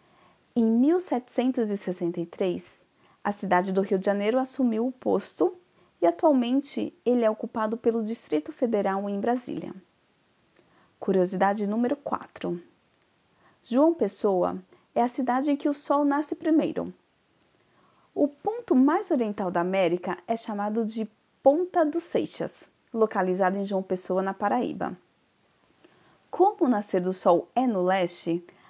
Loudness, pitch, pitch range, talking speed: -26 LUFS, 225 Hz, 190-275 Hz, 130 wpm